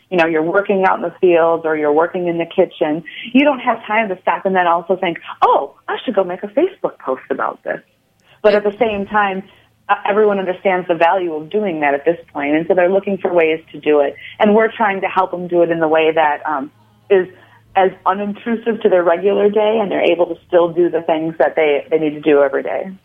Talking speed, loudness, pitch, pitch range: 245 wpm, -16 LUFS, 180 Hz, 160-200 Hz